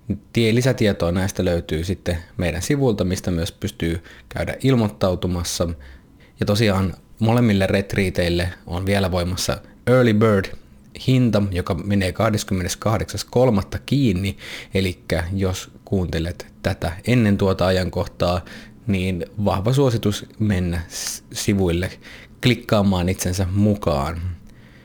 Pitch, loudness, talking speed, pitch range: 95 Hz, -21 LUFS, 95 wpm, 90-105 Hz